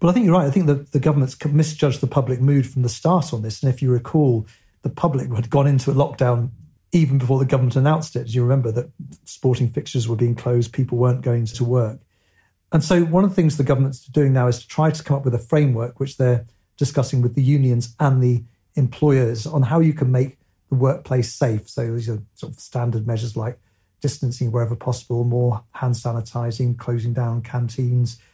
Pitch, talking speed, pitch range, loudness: 125 Hz, 225 wpm, 120-140 Hz, -20 LUFS